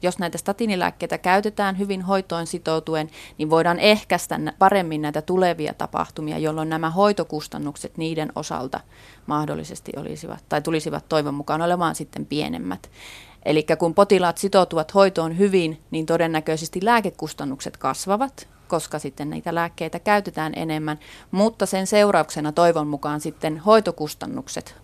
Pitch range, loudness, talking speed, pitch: 155-190 Hz, -22 LUFS, 125 wpm, 165 Hz